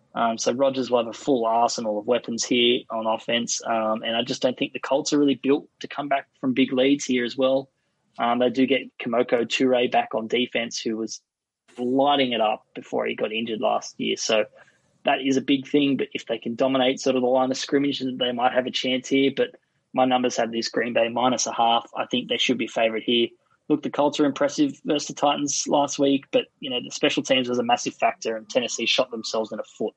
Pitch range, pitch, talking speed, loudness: 115-140 Hz, 130 Hz, 240 wpm, -23 LUFS